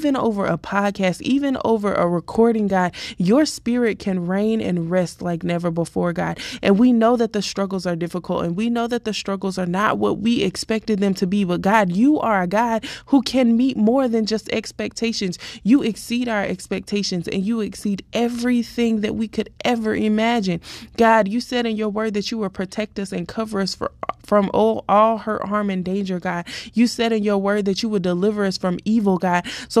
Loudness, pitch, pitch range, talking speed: -20 LUFS, 215 Hz, 195-230 Hz, 205 wpm